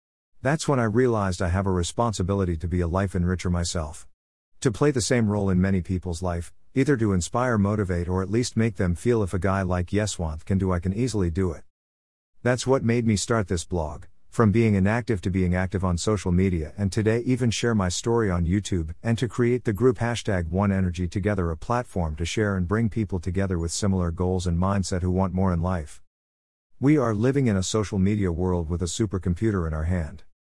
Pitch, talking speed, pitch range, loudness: 95 Hz, 215 wpm, 90-115 Hz, -25 LUFS